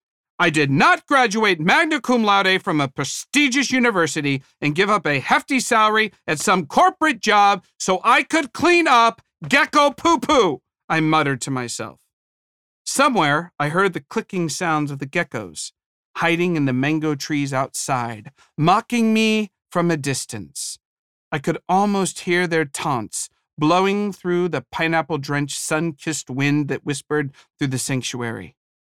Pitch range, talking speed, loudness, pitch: 145-220 Hz, 150 wpm, -19 LUFS, 170 Hz